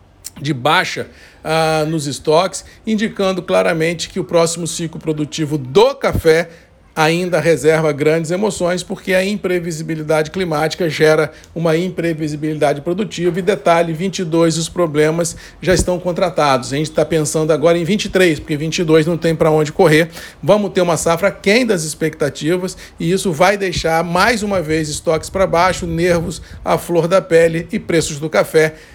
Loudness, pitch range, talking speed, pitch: -16 LUFS, 155-185 Hz, 155 wpm, 165 Hz